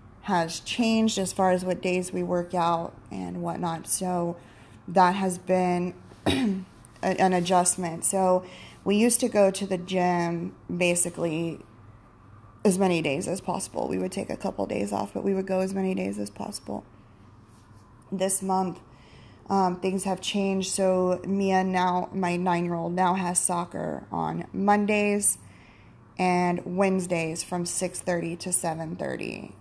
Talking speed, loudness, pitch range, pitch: 150 wpm, -26 LUFS, 165-190 Hz, 180 Hz